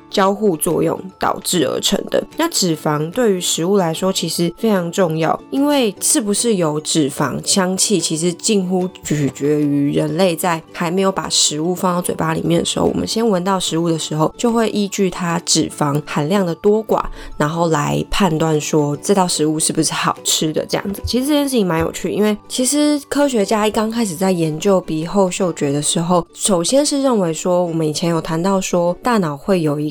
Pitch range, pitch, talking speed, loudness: 160-205 Hz, 180 Hz, 300 characters per minute, -17 LUFS